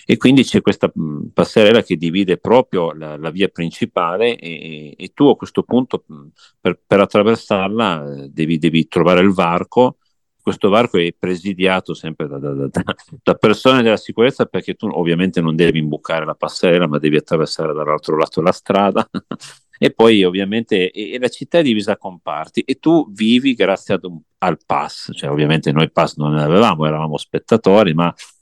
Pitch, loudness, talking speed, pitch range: 85 Hz, -16 LUFS, 170 wpm, 80-100 Hz